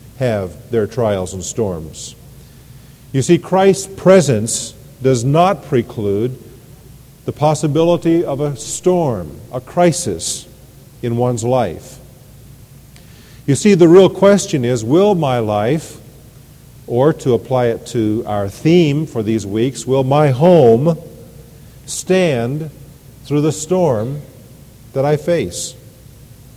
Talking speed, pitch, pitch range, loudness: 115 wpm, 130 Hz, 120-155 Hz, -15 LUFS